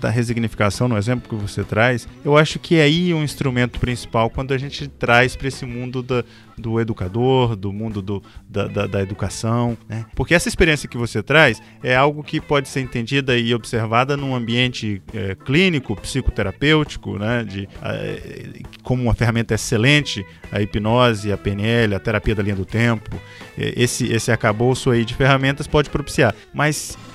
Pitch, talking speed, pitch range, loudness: 120 Hz, 170 wpm, 110-135 Hz, -19 LUFS